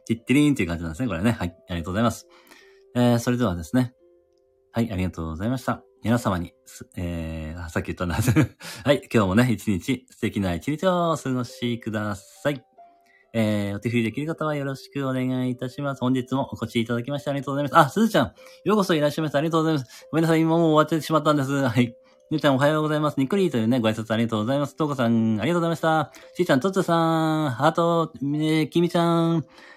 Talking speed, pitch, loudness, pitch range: 520 characters per minute, 130 Hz, -24 LUFS, 115-160 Hz